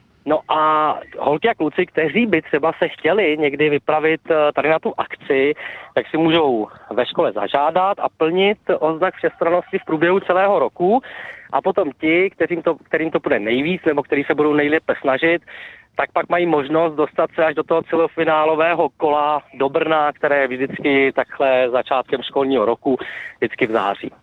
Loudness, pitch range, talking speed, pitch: -18 LUFS, 150-170 Hz, 170 wpm, 160 Hz